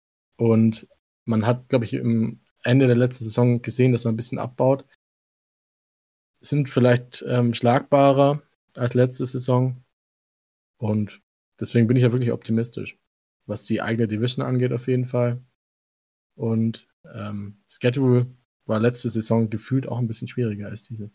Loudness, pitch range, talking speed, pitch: -22 LUFS, 115-125 Hz, 145 wpm, 120 Hz